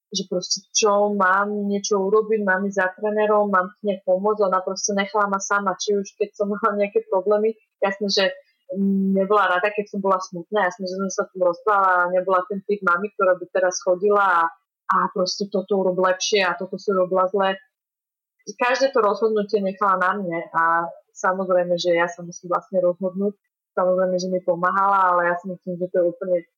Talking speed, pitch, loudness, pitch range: 195 wpm, 195 Hz, -21 LUFS, 185-205 Hz